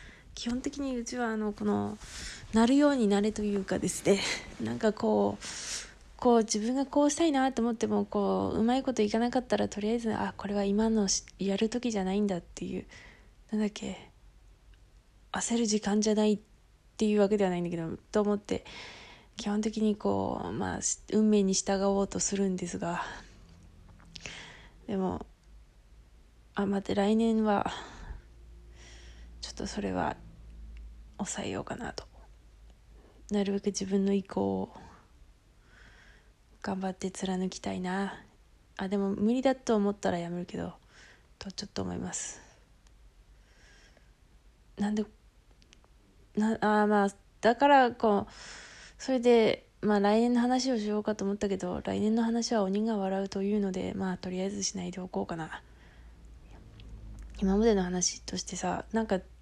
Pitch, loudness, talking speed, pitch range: 205 Hz, -30 LUFS, 275 characters per minute, 185-220 Hz